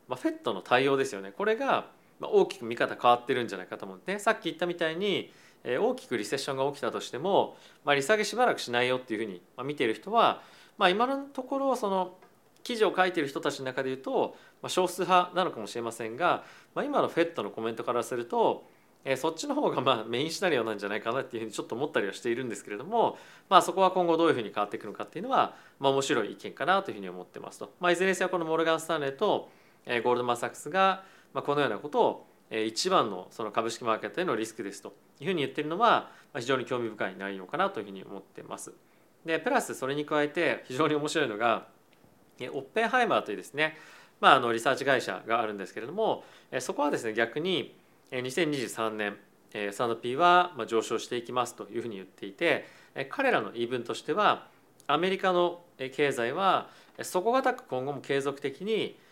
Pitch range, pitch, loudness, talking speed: 120-180 Hz, 145 Hz, -29 LUFS, 465 characters per minute